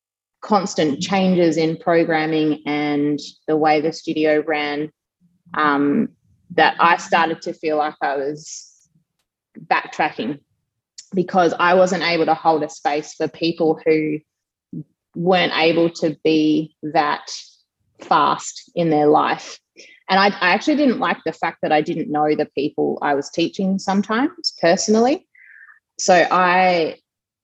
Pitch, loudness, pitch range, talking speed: 160 Hz, -19 LUFS, 150-180 Hz, 135 wpm